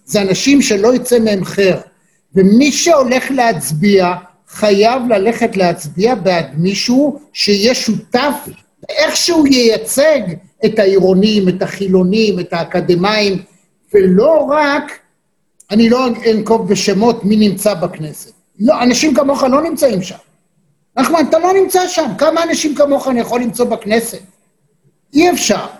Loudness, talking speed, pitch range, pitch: -12 LUFS, 125 wpm, 190-265 Hz, 215 Hz